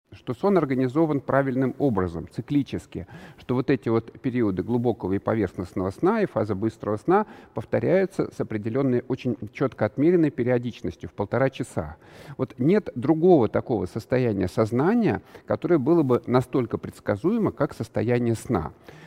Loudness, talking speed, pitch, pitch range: -24 LUFS, 135 wpm, 125 Hz, 110-135 Hz